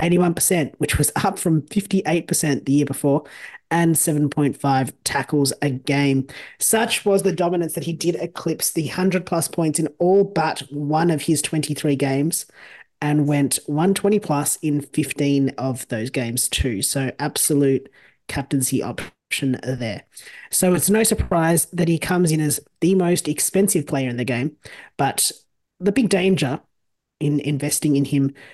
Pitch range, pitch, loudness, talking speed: 140-175 Hz, 150 Hz, -20 LUFS, 155 wpm